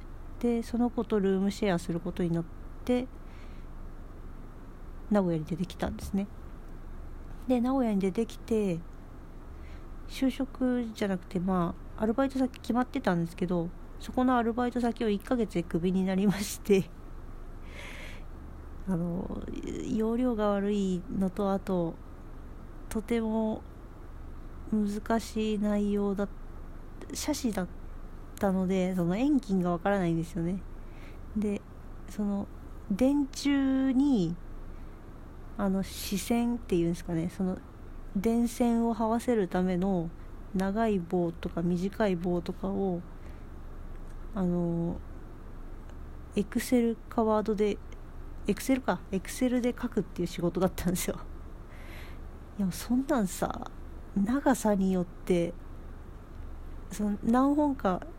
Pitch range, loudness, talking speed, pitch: 175-230 Hz, -30 LUFS, 220 characters per minute, 195 Hz